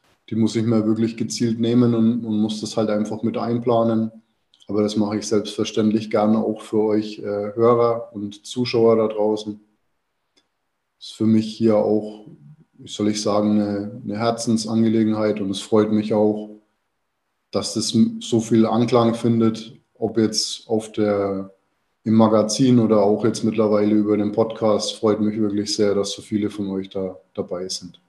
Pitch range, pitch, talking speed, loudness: 105-115 Hz, 110 Hz, 170 wpm, -20 LUFS